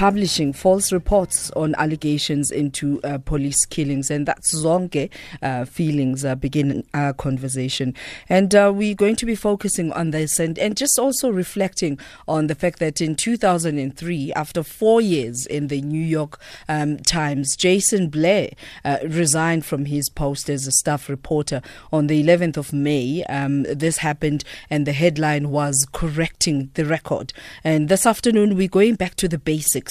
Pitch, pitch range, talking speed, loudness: 155 Hz, 145-180 Hz, 165 wpm, -20 LUFS